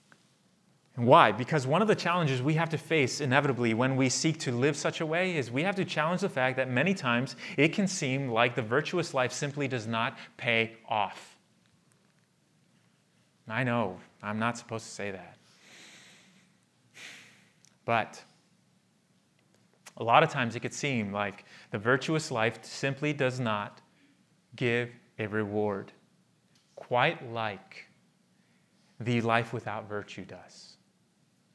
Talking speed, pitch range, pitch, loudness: 140 wpm, 115-150 Hz, 130 Hz, -29 LUFS